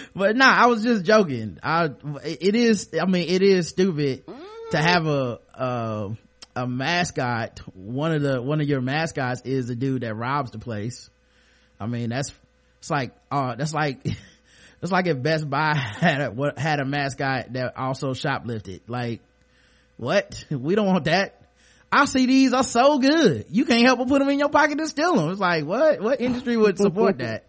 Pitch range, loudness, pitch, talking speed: 130-210 Hz, -22 LUFS, 150 Hz, 190 wpm